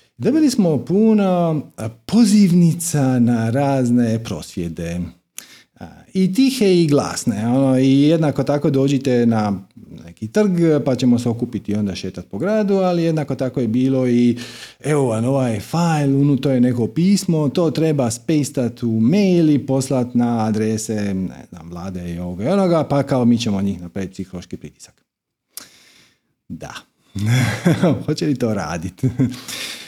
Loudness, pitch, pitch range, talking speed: -18 LUFS, 130 Hz, 110-160 Hz, 140 wpm